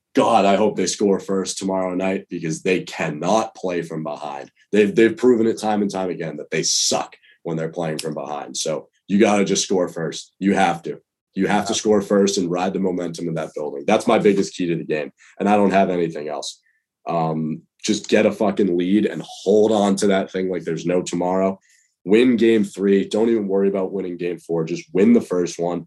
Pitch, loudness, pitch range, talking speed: 95 Hz, -20 LUFS, 85-100 Hz, 225 wpm